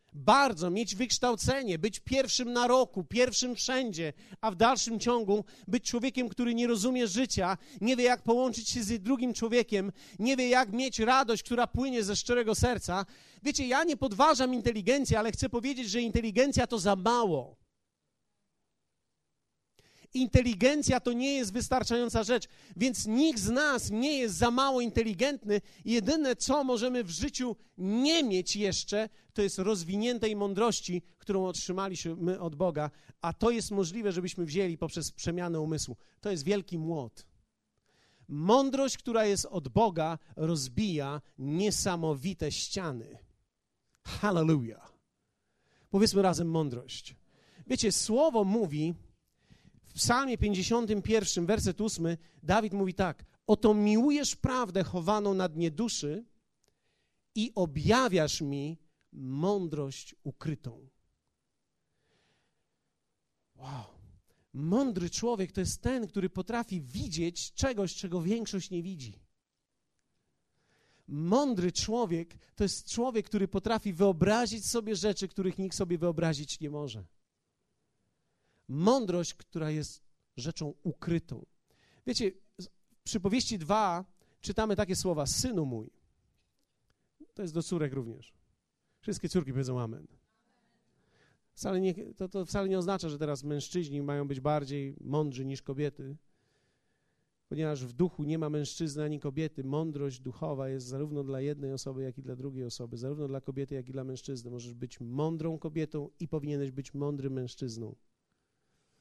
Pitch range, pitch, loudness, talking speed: 150-230 Hz, 185 Hz, -31 LUFS, 130 wpm